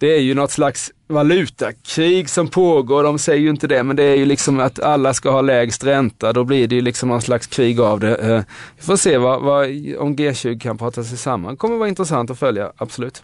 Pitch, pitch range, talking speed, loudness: 135 Hz, 120-150 Hz, 230 wpm, -17 LUFS